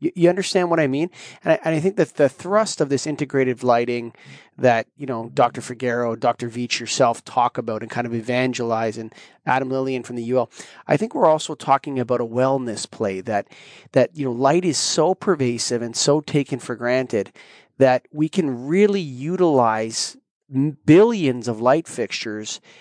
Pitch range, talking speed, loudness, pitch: 120-155 Hz, 180 wpm, -21 LUFS, 130 Hz